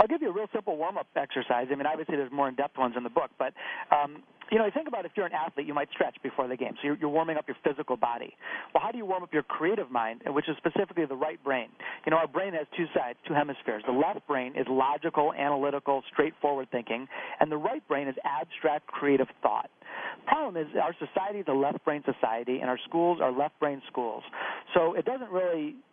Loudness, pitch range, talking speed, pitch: -30 LUFS, 135-165 Hz, 245 wpm, 145 Hz